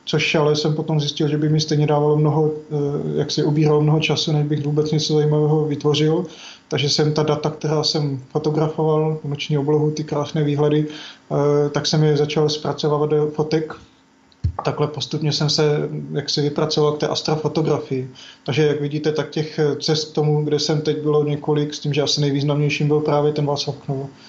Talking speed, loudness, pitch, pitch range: 180 wpm, -20 LUFS, 150 Hz, 145-155 Hz